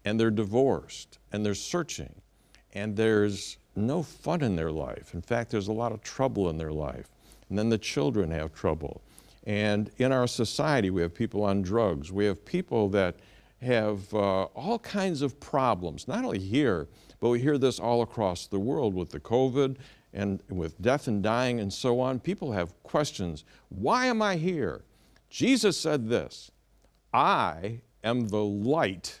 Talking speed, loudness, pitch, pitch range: 175 wpm, -29 LUFS, 110 Hz, 100-130 Hz